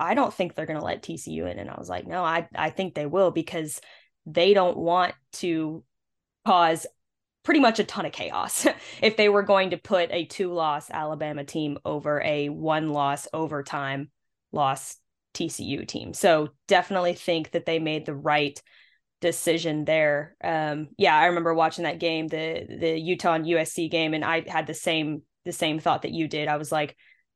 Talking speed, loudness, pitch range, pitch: 190 wpm, -25 LUFS, 150-175 Hz, 160 Hz